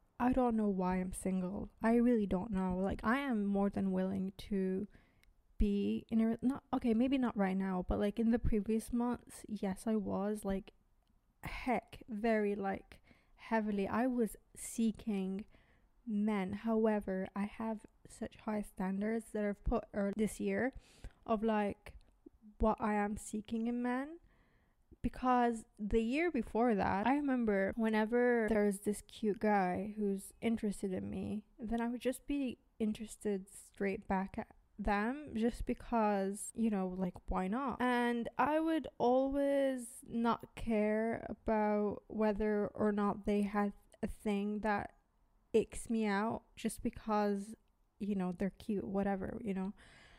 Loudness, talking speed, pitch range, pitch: -36 LUFS, 150 wpm, 200-230 Hz, 215 Hz